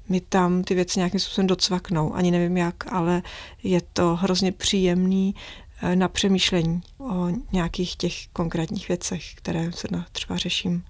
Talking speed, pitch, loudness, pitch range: 145 wpm, 180 Hz, -24 LUFS, 175-185 Hz